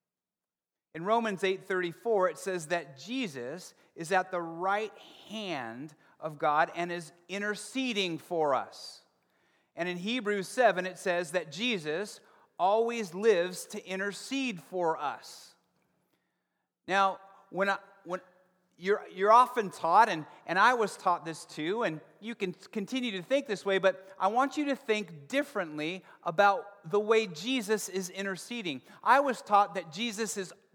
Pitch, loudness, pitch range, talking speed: 195 Hz, -30 LUFS, 180-215 Hz, 150 wpm